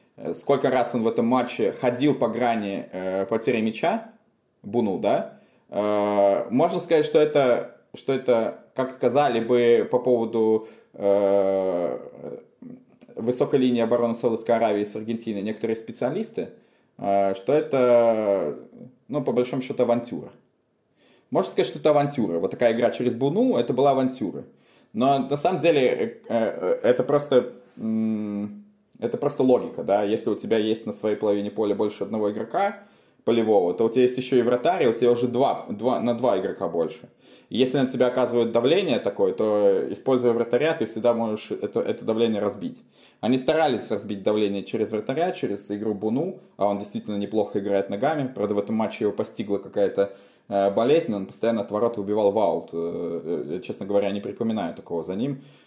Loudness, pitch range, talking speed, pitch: -24 LUFS, 105-130 Hz, 165 wpm, 115 Hz